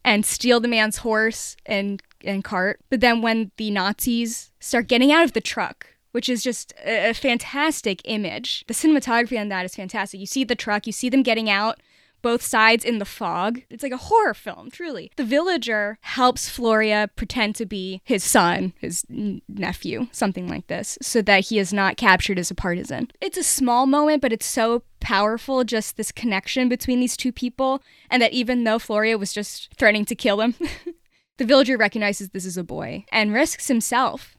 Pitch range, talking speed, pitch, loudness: 210-255 Hz, 195 wpm, 230 Hz, -21 LUFS